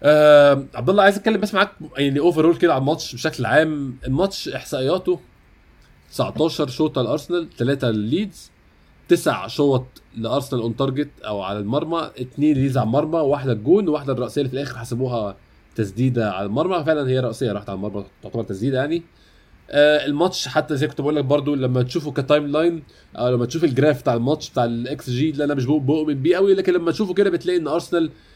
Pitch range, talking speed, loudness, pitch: 120-160 Hz, 180 wpm, -20 LUFS, 145 Hz